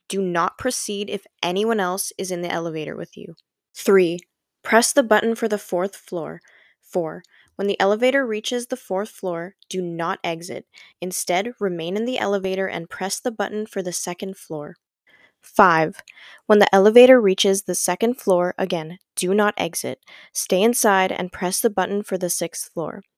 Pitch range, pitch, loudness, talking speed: 180-215 Hz, 195 Hz, -21 LUFS, 170 wpm